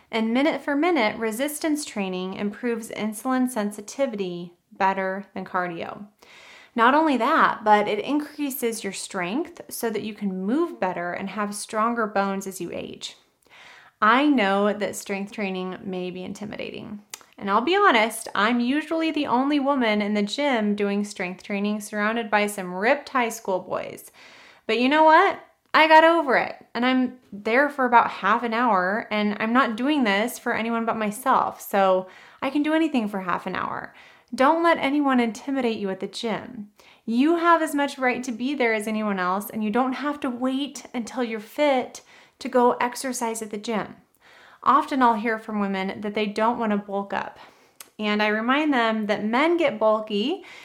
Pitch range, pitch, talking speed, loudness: 205-270 Hz, 225 Hz, 180 wpm, -23 LUFS